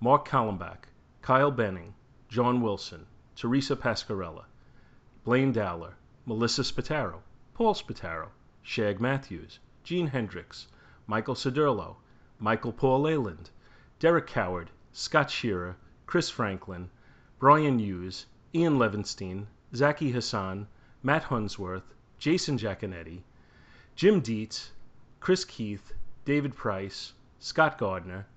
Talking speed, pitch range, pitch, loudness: 100 wpm, 95-135 Hz, 115 Hz, -29 LUFS